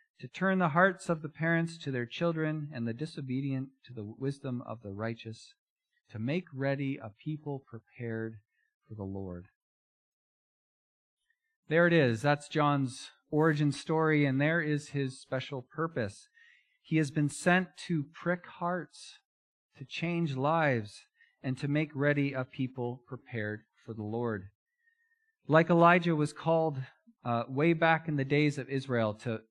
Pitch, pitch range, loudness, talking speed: 145 Hz, 125-165 Hz, -31 LUFS, 150 wpm